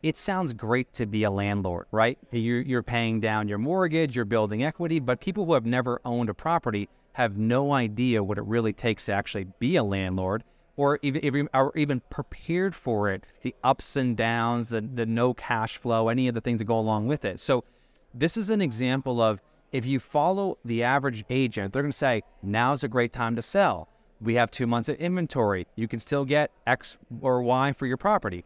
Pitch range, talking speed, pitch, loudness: 110-140 Hz, 205 wpm, 120 Hz, -27 LUFS